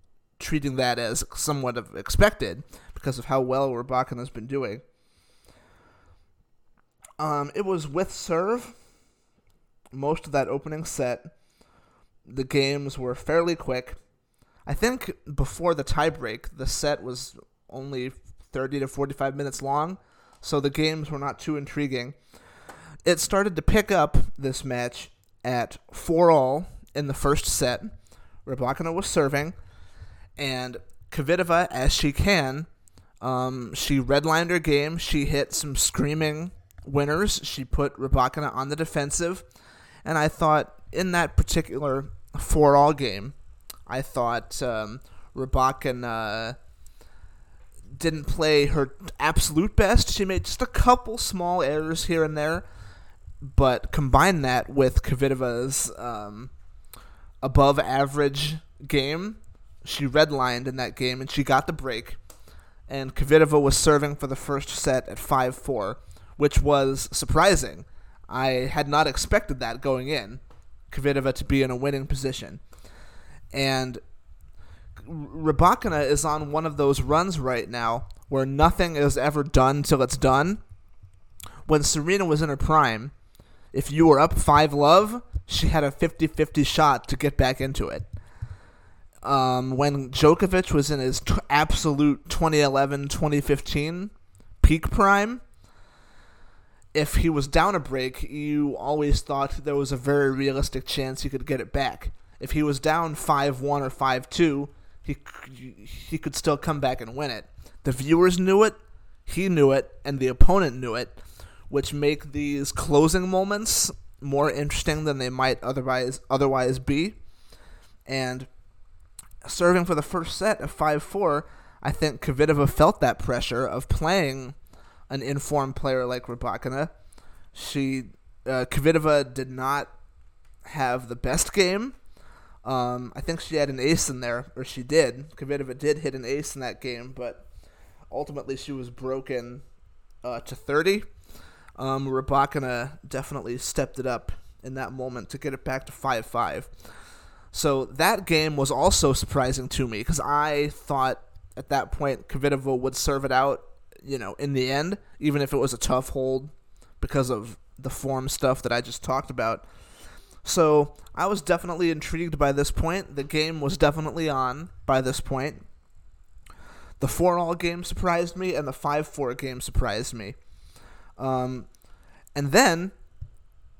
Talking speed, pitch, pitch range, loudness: 145 wpm, 140 Hz, 125-150 Hz, -25 LUFS